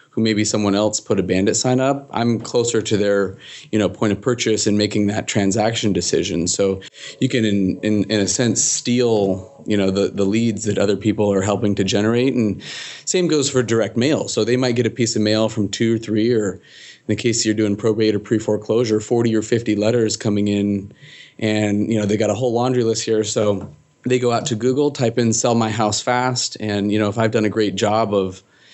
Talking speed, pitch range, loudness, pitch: 230 wpm, 105-115 Hz, -19 LUFS, 110 Hz